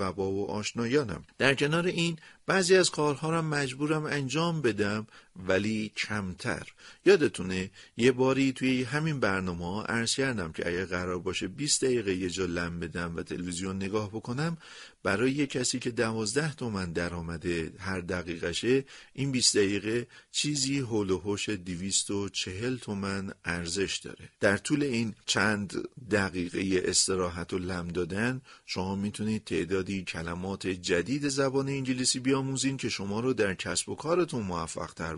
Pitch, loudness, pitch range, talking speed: 105 Hz, -30 LUFS, 95-135 Hz, 145 wpm